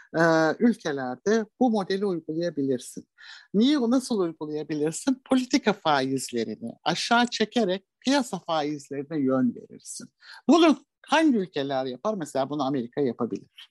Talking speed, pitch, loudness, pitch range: 100 wpm, 175 Hz, -25 LUFS, 145-235 Hz